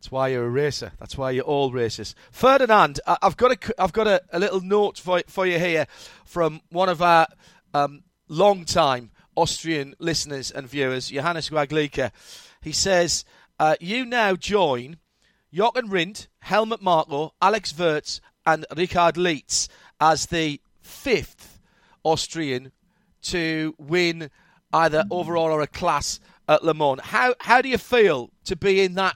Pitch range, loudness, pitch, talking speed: 150-190 Hz, -22 LUFS, 165 Hz, 150 wpm